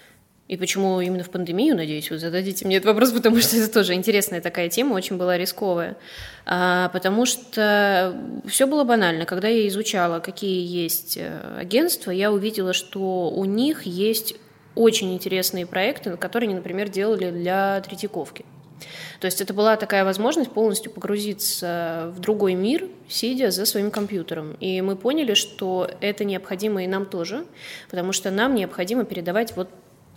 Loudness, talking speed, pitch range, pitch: -22 LUFS, 155 wpm, 180-220 Hz, 195 Hz